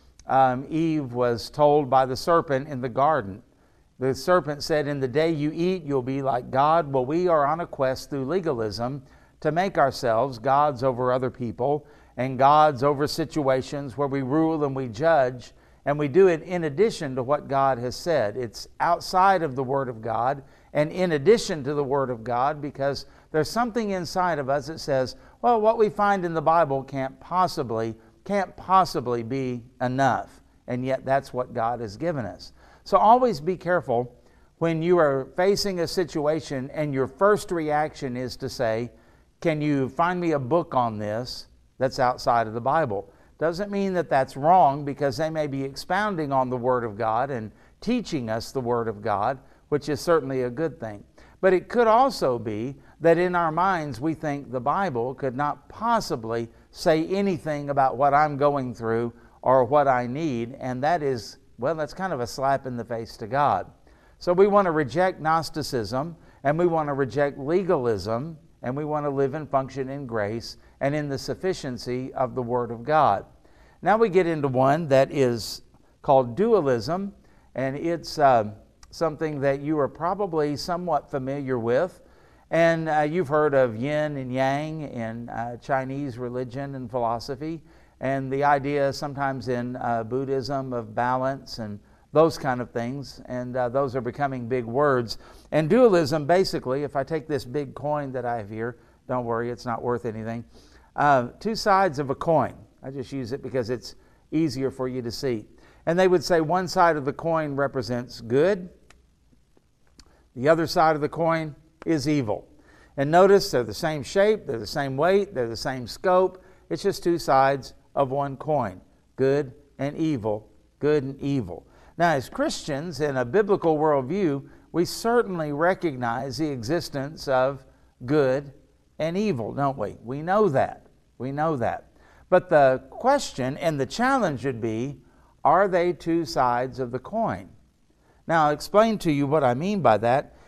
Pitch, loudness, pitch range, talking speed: 140 Hz, -24 LUFS, 125-160 Hz, 180 wpm